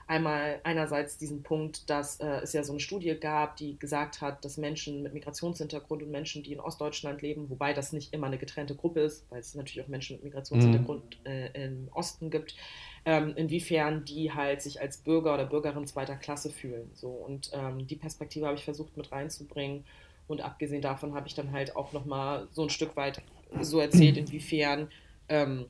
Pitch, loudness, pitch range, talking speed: 145 Hz, -32 LUFS, 140-155 Hz, 195 wpm